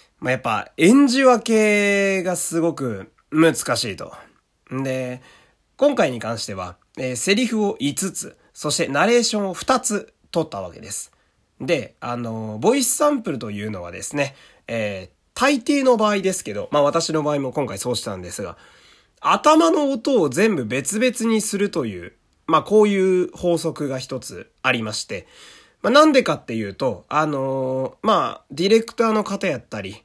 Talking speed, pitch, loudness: 285 characters per minute, 165 Hz, -20 LUFS